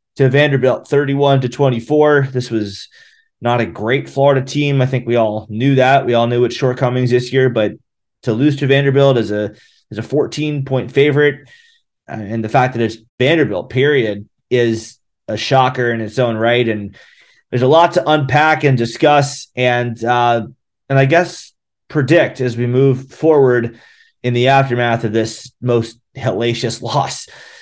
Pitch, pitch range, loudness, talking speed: 125 Hz, 115-140 Hz, -15 LUFS, 165 wpm